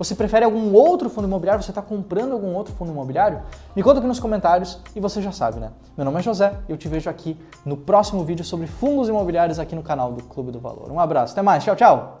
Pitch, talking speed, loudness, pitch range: 185 Hz, 250 wpm, -20 LUFS, 160-210 Hz